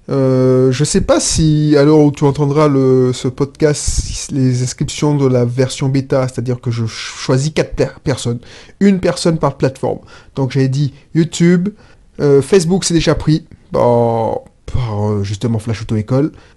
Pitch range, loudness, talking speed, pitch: 125-155 Hz, -14 LUFS, 155 wpm, 135 Hz